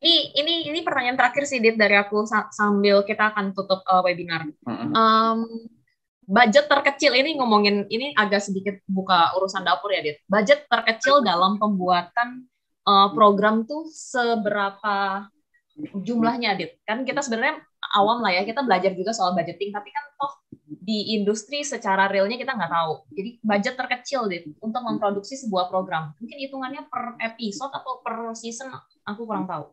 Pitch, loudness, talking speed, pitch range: 220 Hz, -22 LUFS, 155 wpm, 195-255 Hz